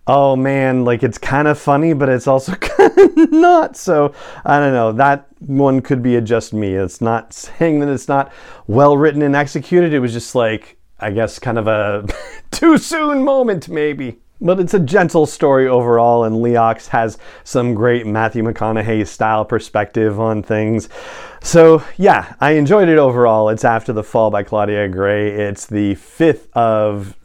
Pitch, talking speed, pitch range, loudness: 125 Hz, 180 wpm, 110-150 Hz, -14 LUFS